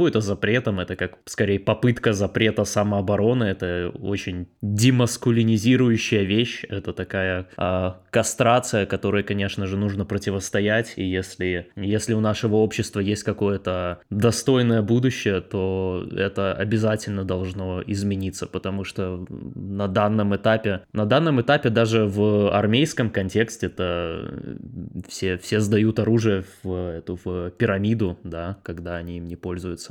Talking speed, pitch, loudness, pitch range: 125 wpm, 100 Hz, -23 LUFS, 95-110 Hz